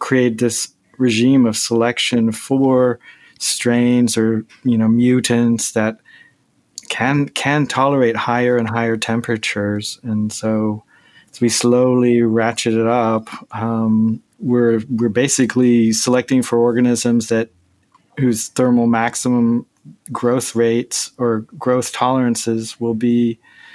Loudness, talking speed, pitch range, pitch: -17 LUFS, 115 wpm, 115-125 Hz, 120 Hz